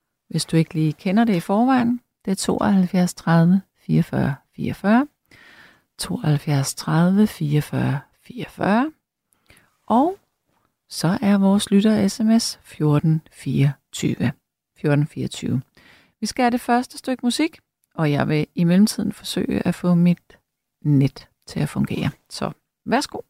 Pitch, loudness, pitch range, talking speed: 185 Hz, -21 LUFS, 155-225 Hz, 130 wpm